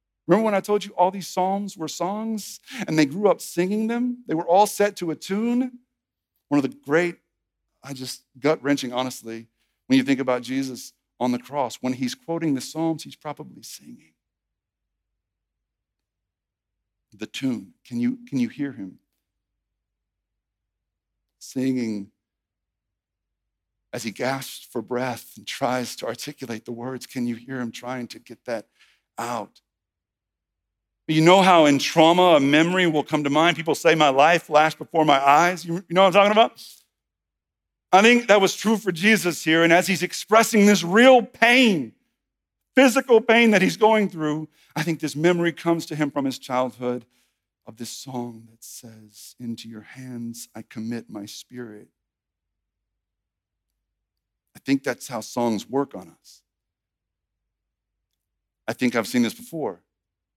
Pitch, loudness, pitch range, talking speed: 130 Hz, -21 LUFS, 105-170 Hz, 160 wpm